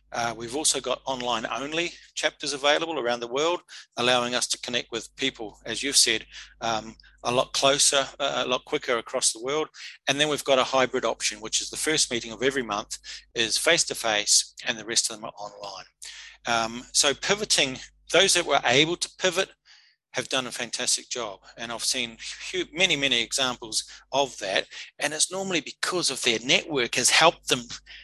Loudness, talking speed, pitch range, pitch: -24 LUFS, 190 wpm, 120-150 Hz, 130 Hz